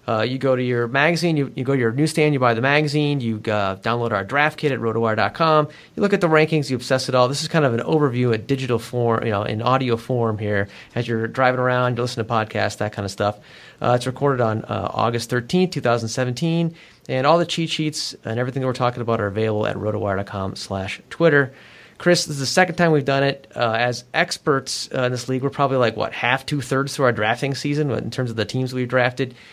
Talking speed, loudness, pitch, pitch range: 240 wpm, -21 LUFS, 125 Hz, 115-145 Hz